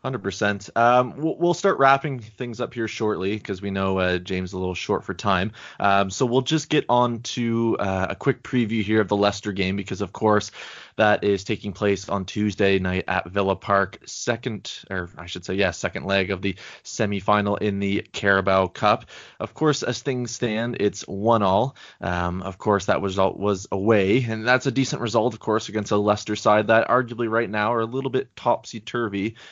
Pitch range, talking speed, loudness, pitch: 100-120 Hz, 205 wpm, -23 LUFS, 105 Hz